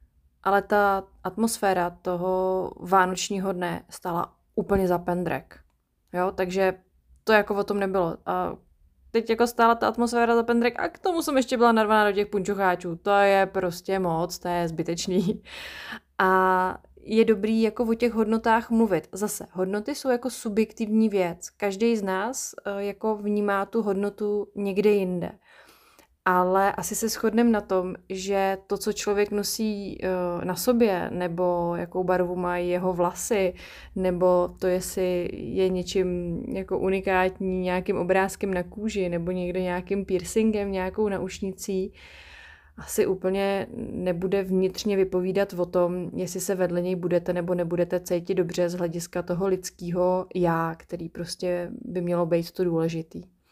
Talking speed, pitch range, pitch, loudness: 145 wpm, 180-205 Hz, 190 Hz, -25 LUFS